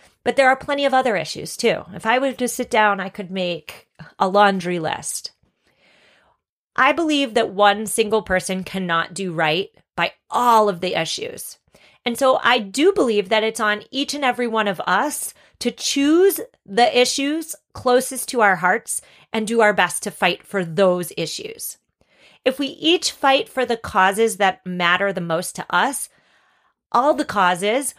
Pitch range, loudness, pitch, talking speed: 190-265 Hz, -19 LUFS, 225 Hz, 175 wpm